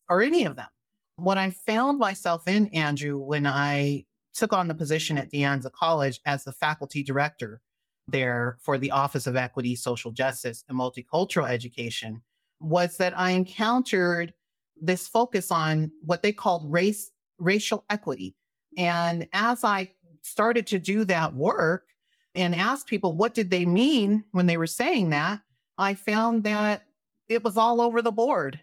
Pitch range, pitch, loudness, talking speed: 140-210 Hz, 175 Hz, -26 LUFS, 160 wpm